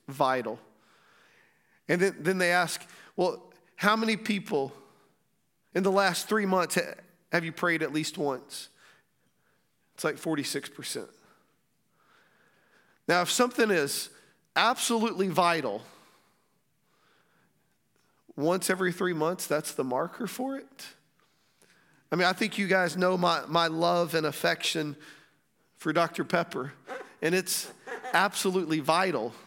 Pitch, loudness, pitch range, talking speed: 180 Hz, -28 LUFS, 165-195 Hz, 120 wpm